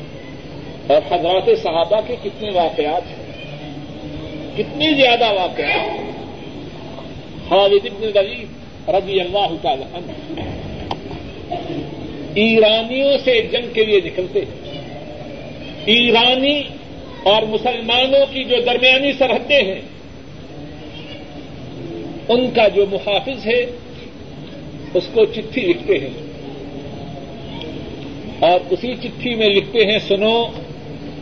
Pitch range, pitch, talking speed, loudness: 150-245 Hz, 205 Hz, 90 wpm, -16 LUFS